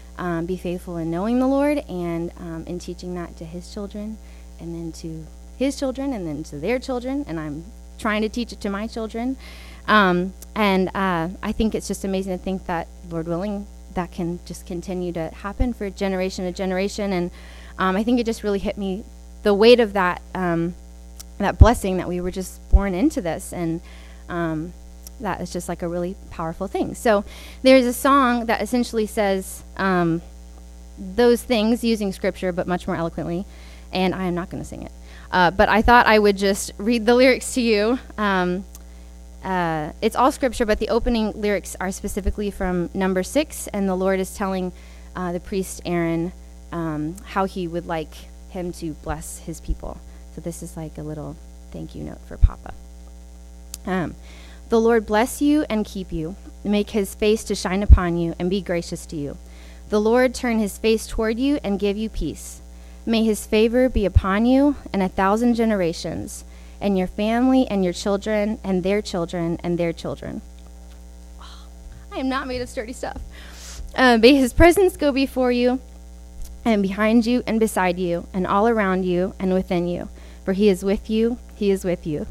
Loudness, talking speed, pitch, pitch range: -22 LUFS, 190 wpm, 185 Hz, 165-215 Hz